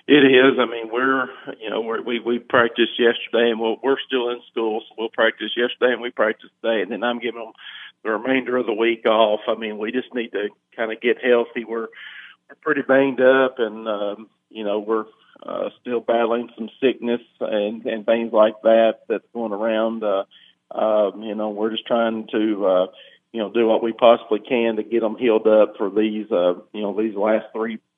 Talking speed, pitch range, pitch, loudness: 215 wpm, 110-120 Hz, 115 Hz, -21 LUFS